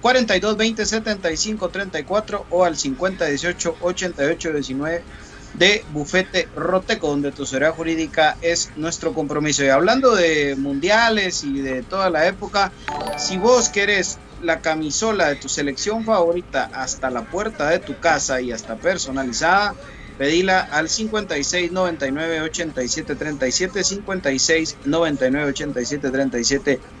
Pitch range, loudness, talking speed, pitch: 140-190 Hz, -20 LUFS, 130 wpm, 165 Hz